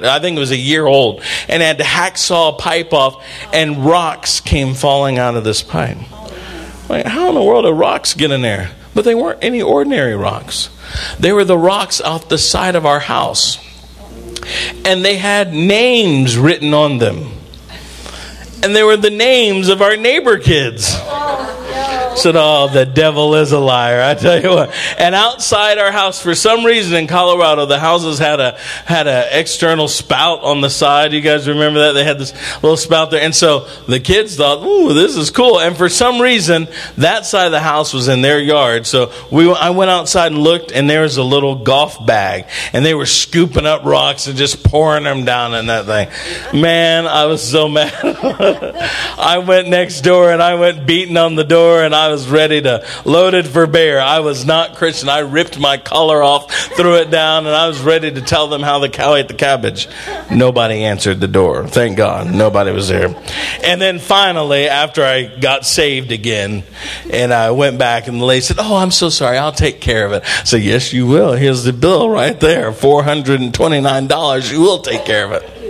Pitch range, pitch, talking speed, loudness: 135-175 Hz, 155 Hz, 210 wpm, -12 LUFS